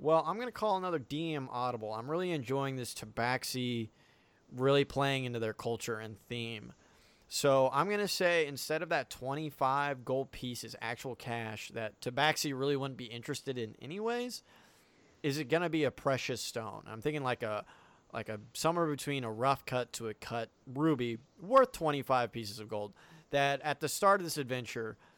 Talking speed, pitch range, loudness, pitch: 180 wpm, 115-155 Hz, -34 LUFS, 135 Hz